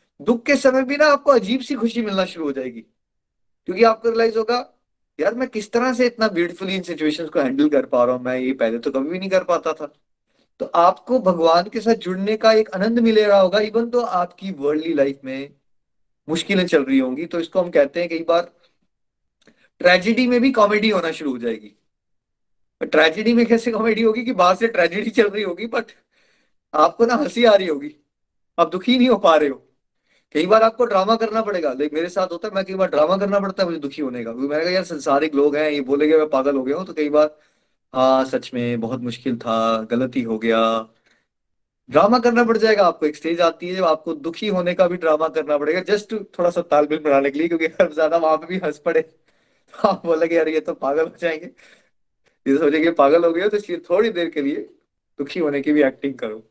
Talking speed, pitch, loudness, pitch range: 225 wpm, 170 Hz, -19 LUFS, 150-215 Hz